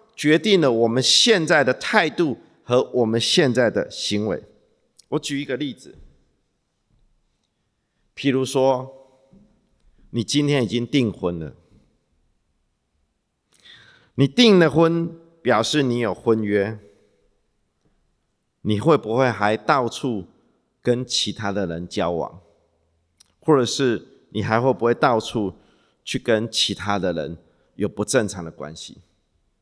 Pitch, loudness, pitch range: 120 Hz, -20 LUFS, 100-135 Hz